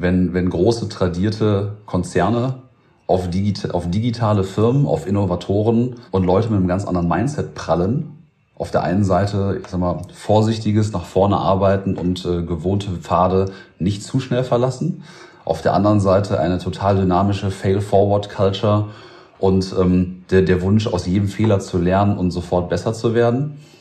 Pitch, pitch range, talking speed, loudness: 100 Hz, 90-110 Hz, 160 wpm, -19 LUFS